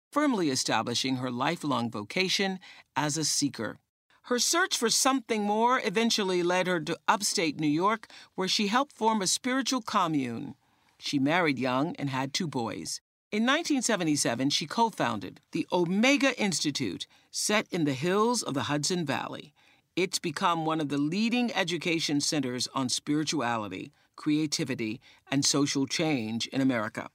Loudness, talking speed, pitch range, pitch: -28 LUFS, 145 wpm, 145-220 Hz, 170 Hz